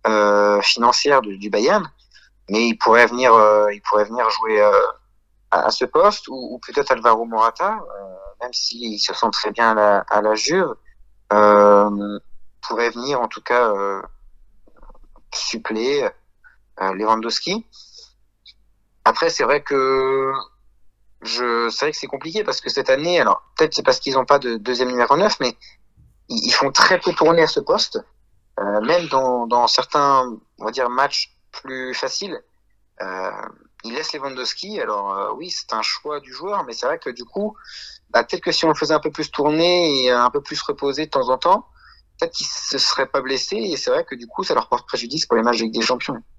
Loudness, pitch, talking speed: -18 LUFS, 130 Hz, 200 wpm